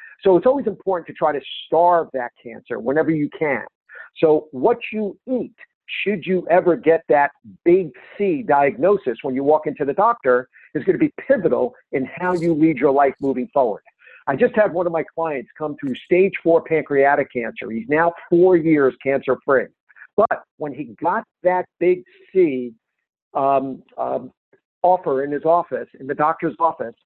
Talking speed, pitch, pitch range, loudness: 175 wpm, 165 Hz, 145-190 Hz, -20 LUFS